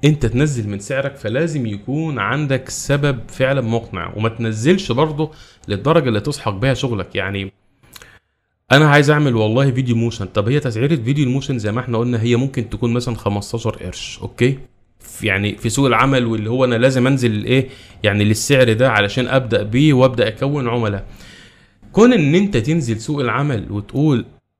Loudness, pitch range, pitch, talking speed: -17 LUFS, 110-140 Hz, 125 Hz, 165 wpm